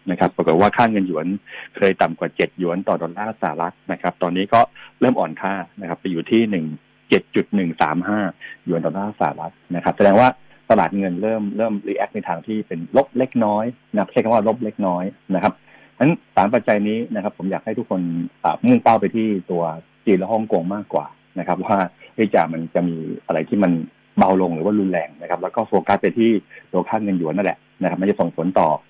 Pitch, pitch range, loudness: 100 Hz, 85-110 Hz, -20 LUFS